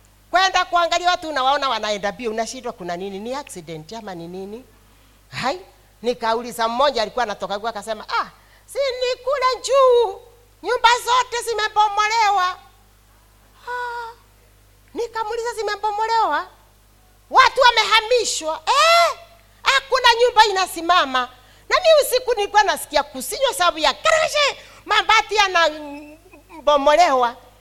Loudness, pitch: -18 LUFS, 345 Hz